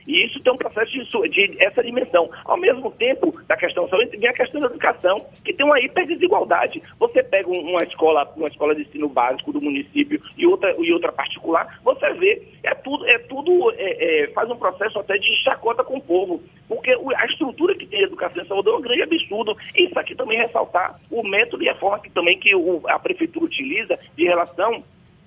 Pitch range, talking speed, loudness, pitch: 235-395 Hz, 210 wpm, -20 LUFS, 300 Hz